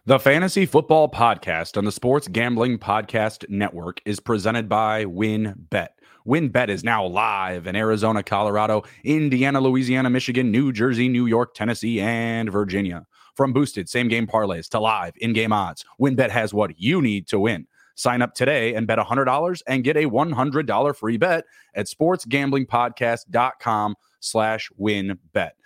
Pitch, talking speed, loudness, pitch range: 115 Hz, 160 wpm, -21 LUFS, 105-130 Hz